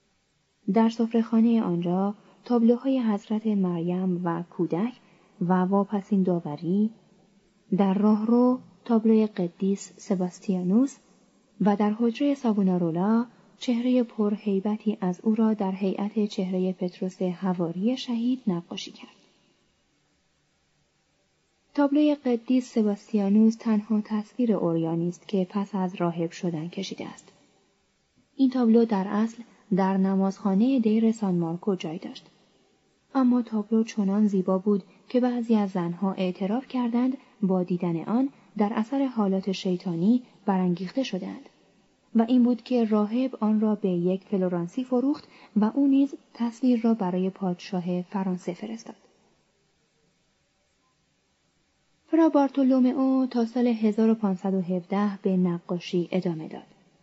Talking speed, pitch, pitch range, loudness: 115 wpm, 205 Hz, 185-235 Hz, -26 LUFS